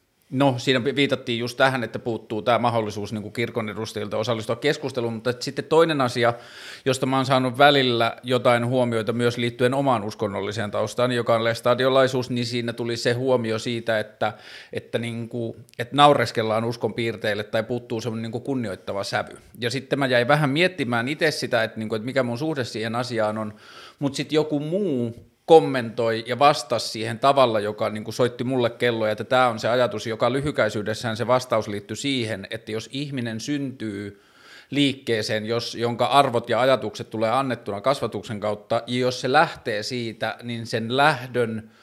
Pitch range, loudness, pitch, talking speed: 110-130 Hz, -23 LUFS, 120 Hz, 170 wpm